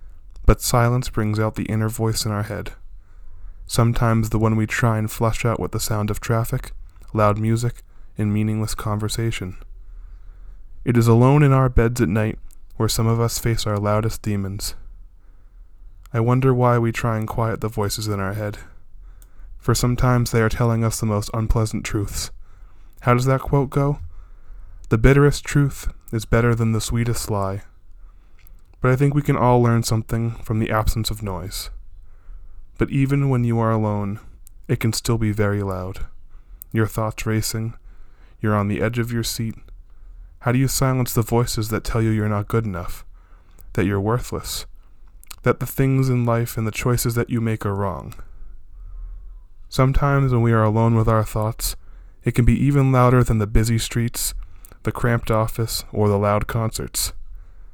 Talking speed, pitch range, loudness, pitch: 175 wpm, 90-115 Hz, -21 LUFS, 110 Hz